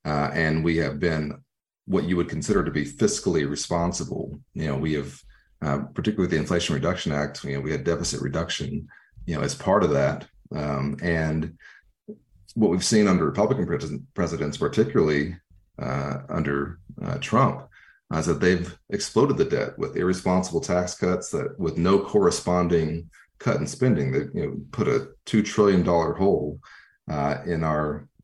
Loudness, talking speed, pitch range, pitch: -25 LUFS, 165 wpm, 75-90 Hz, 80 Hz